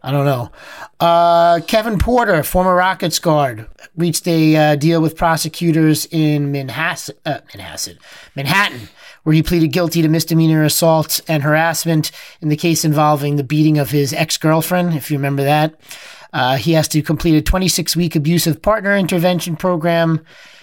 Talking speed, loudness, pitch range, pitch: 155 wpm, -15 LUFS, 150-170 Hz, 160 Hz